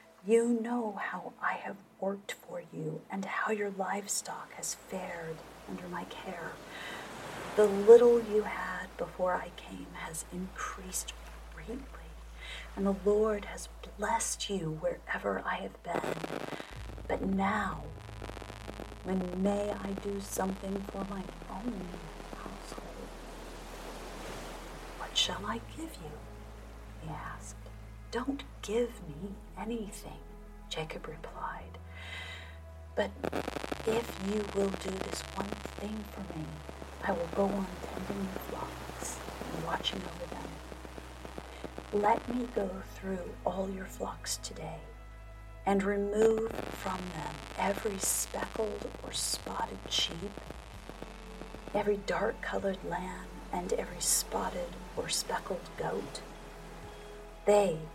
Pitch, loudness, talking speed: 190 Hz, -34 LUFS, 115 wpm